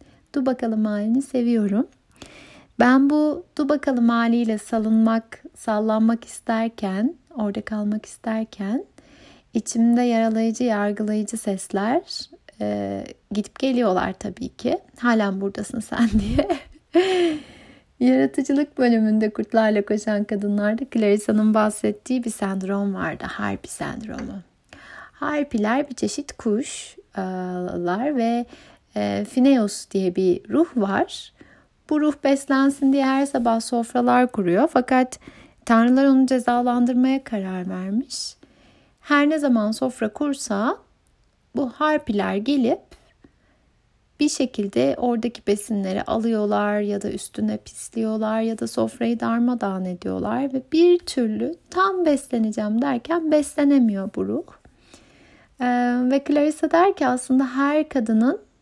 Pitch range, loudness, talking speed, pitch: 210-275 Hz, -22 LUFS, 105 wpm, 235 Hz